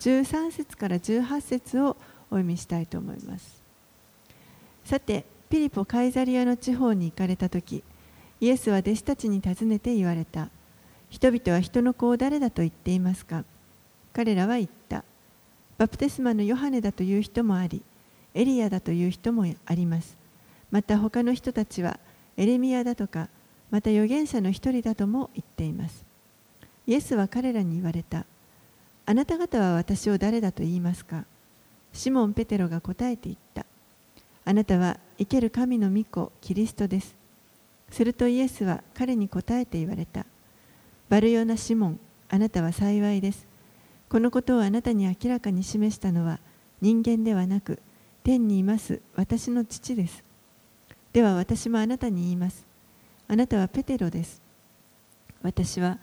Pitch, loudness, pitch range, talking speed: 210 Hz, -26 LUFS, 180-240 Hz, 300 characters per minute